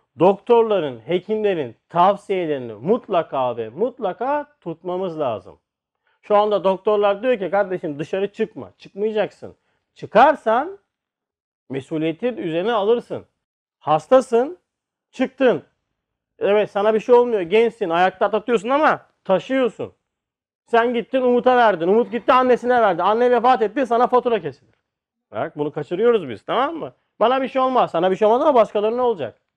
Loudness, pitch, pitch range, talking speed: -19 LUFS, 215 Hz, 180-245 Hz, 130 wpm